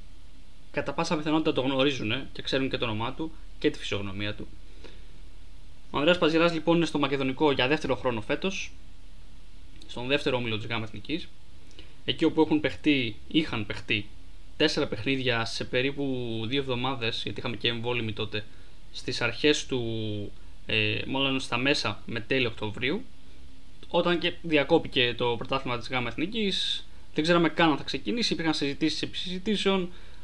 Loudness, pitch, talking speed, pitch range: -28 LUFS, 125 Hz, 150 wpm, 105-150 Hz